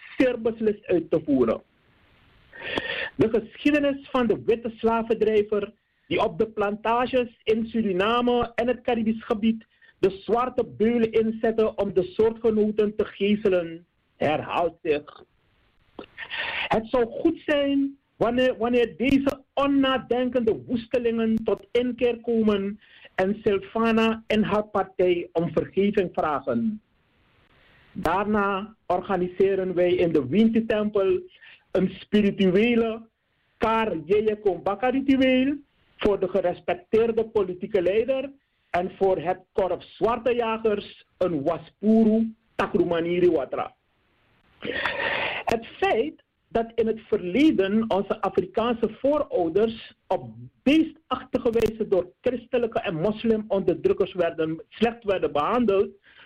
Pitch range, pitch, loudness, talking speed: 195-240 Hz, 220 Hz, -24 LUFS, 100 wpm